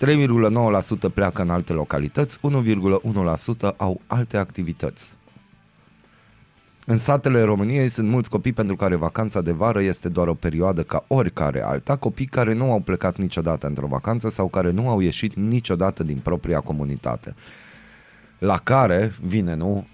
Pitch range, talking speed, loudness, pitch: 85-115 Hz, 145 wpm, -22 LUFS, 100 Hz